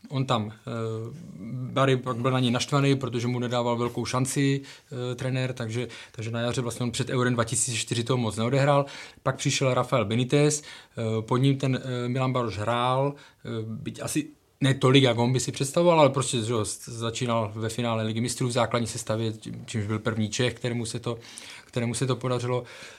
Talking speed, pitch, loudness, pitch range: 185 wpm, 125 Hz, -26 LUFS, 115-130 Hz